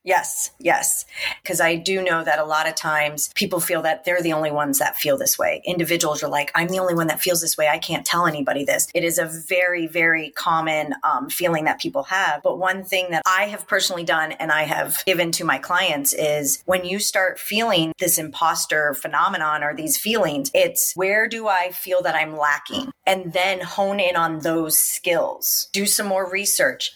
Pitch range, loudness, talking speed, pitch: 155-195 Hz, -20 LUFS, 210 wpm, 175 Hz